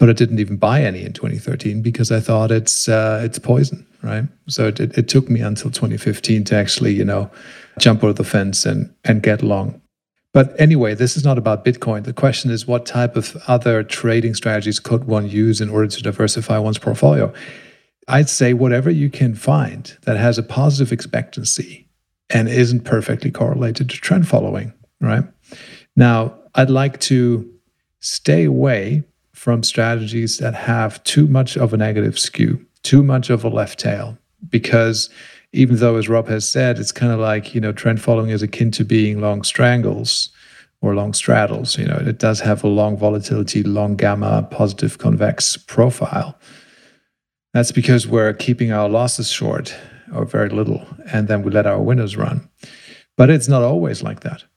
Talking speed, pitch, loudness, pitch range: 175 wpm, 115 Hz, -17 LUFS, 110-130 Hz